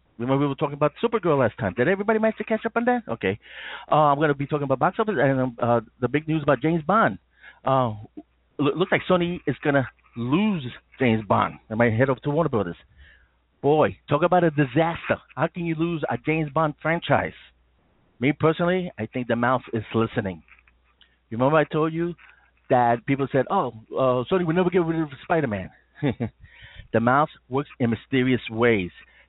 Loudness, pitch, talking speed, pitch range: -23 LUFS, 140 Hz, 195 wpm, 115-165 Hz